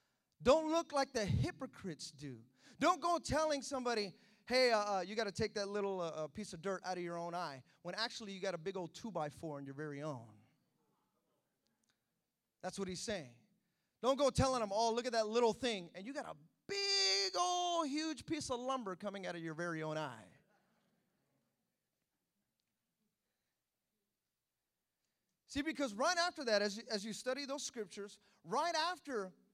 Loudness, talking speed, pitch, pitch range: -38 LUFS, 175 wpm, 205 Hz, 175-255 Hz